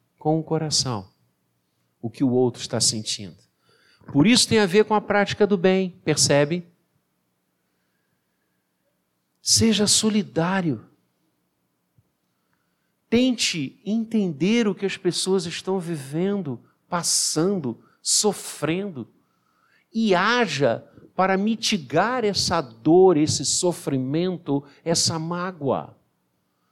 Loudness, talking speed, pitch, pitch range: -22 LUFS, 95 wpm, 165 Hz, 120-195 Hz